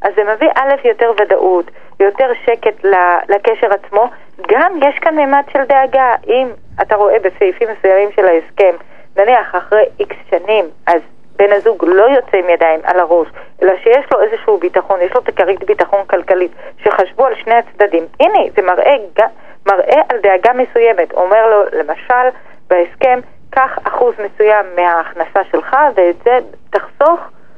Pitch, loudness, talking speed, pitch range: 220 Hz, -12 LUFS, 150 wpm, 190-265 Hz